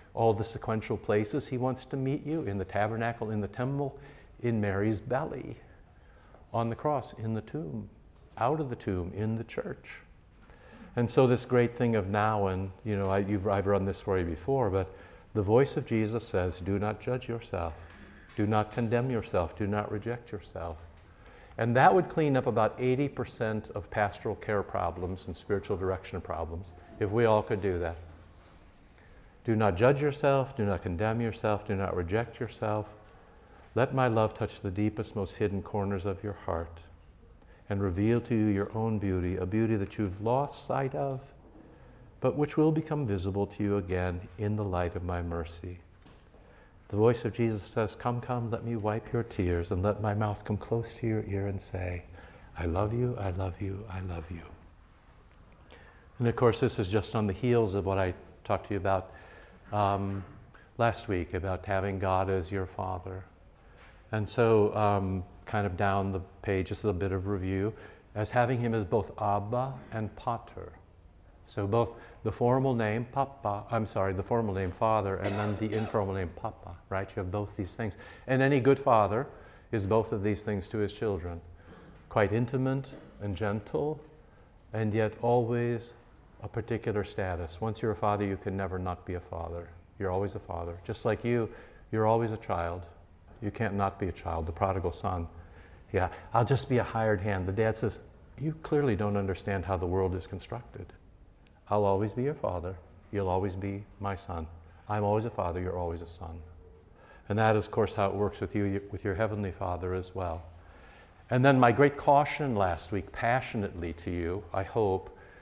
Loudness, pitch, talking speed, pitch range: -31 LUFS, 105 Hz, 185 wpm, 95-115 Hz